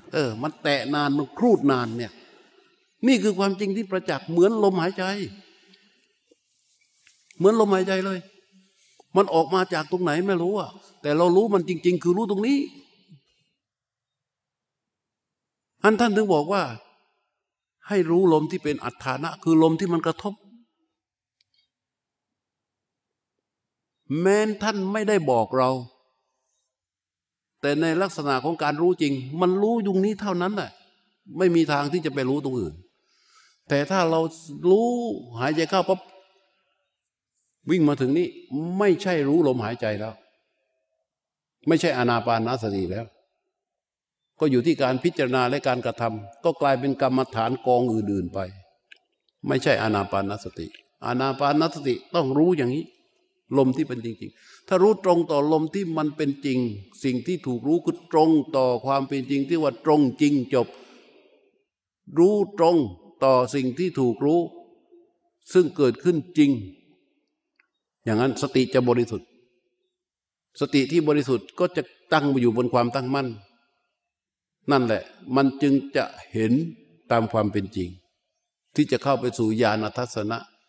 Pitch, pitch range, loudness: 150 Hz, 125-190 Hz, -23 LUFS